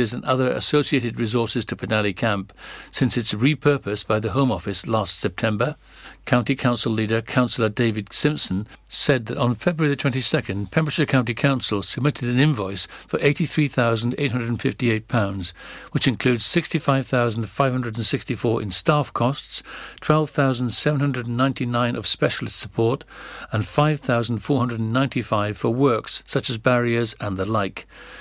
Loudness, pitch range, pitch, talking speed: -22 LUFS, 110-140 Hz, 120 Hz, 120 wpm